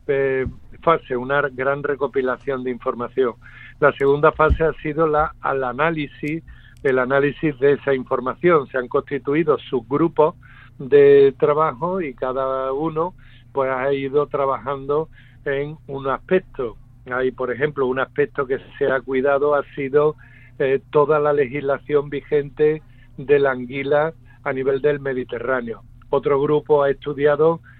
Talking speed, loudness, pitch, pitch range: 135 wpm, -20 LUFS, 140 Hz, 130-150 Hz